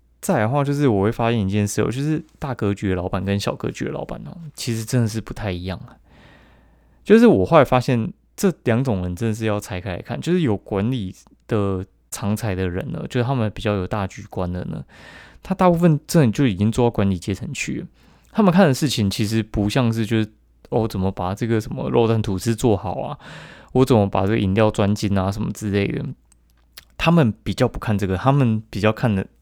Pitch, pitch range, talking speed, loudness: 110 Hz, 100-125 Hz, 315 characters per minute, -21 LUFS